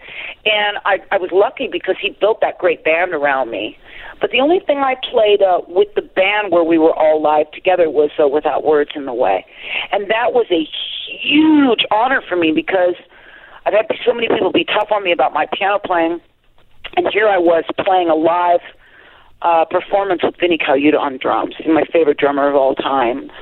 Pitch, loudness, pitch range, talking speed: 180 Hz, -15 LUFS, 160-220 Hz, 200 wpm